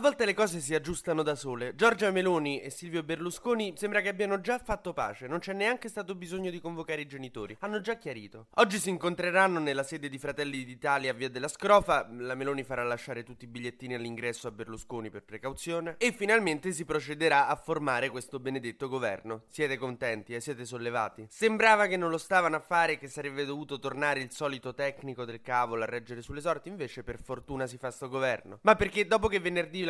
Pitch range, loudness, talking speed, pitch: 125-185 Hz, -31 LUFS, 205 wpm, 145 Hz